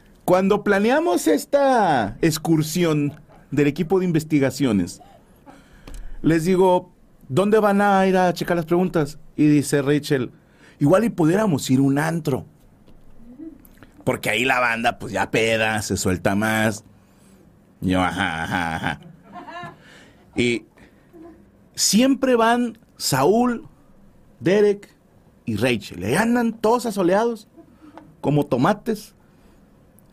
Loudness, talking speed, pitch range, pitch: -20 LUFS, 110 wpm, 130-210 Hz, 160 Hz